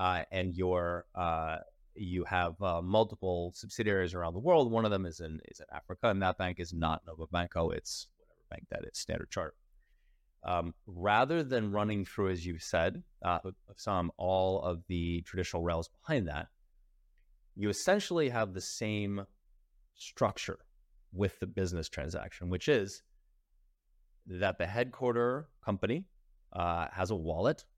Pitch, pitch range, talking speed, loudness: 90 Hz, 85-100 Hz, 155 wpm, -34 LUFS